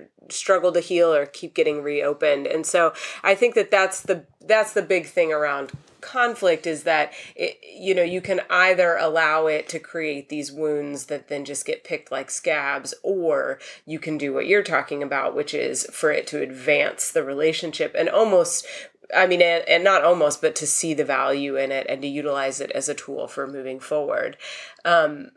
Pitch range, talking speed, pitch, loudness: 145-195 Hz, 195 wpm, 165 Hz, -22 LUFS